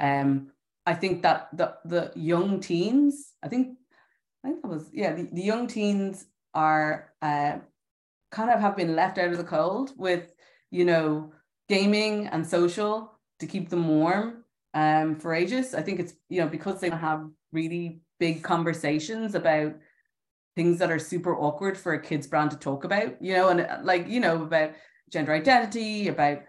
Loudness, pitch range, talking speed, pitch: -27 LUFS, 155-200 Hz, 175 wpm, 175 Hz